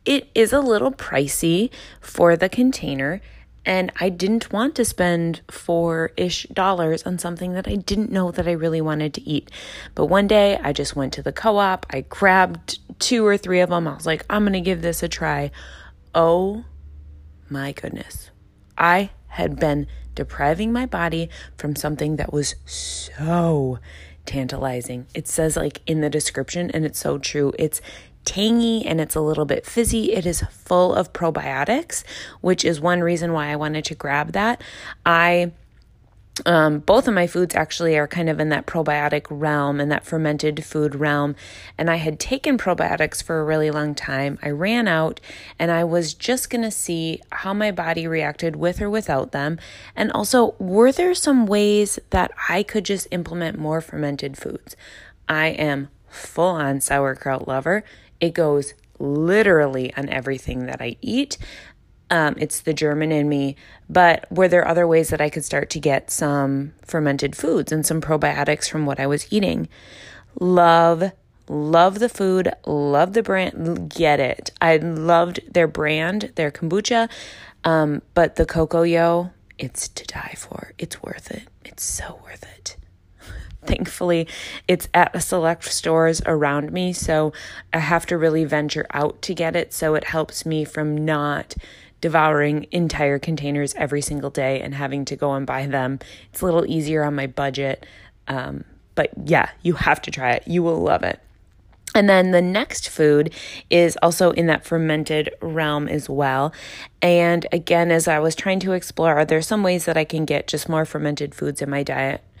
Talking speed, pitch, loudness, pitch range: 175 wpm, 160 Hz, -20 LUFS, 145-175 Hz